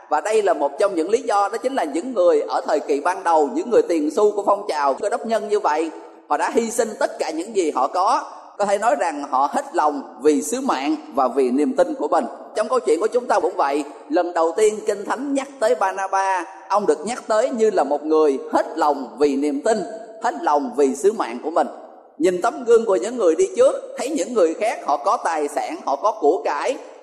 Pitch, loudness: 220 Hz, -20 LUFS